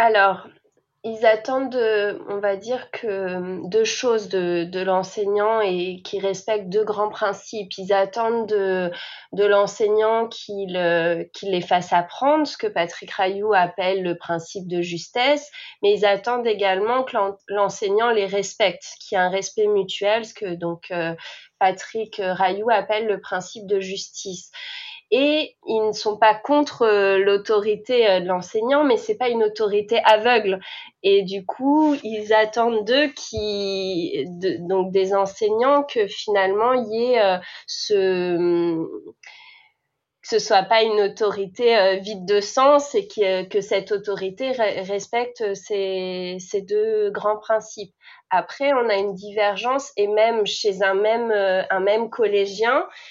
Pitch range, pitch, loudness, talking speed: 190-225 Hz, 205 Hz, -21 LUFS, 140 wpm